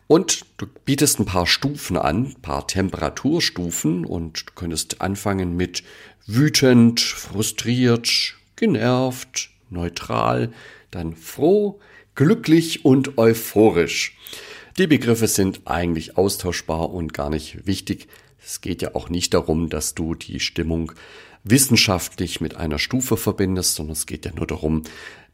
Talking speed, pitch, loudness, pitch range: 130 wpm, 95 Hz, -20 LUFS, 80-115 Hz